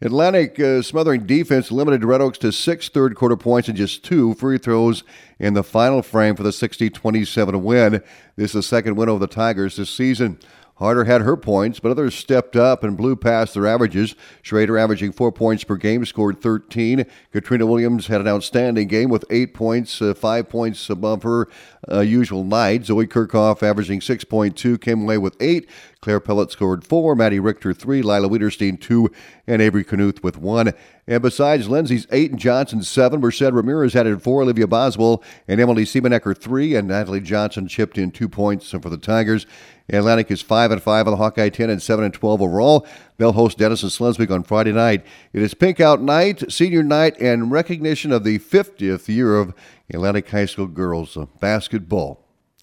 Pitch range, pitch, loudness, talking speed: 105-120 Hz, 110 Hz, -18 LUFS, 185 wpm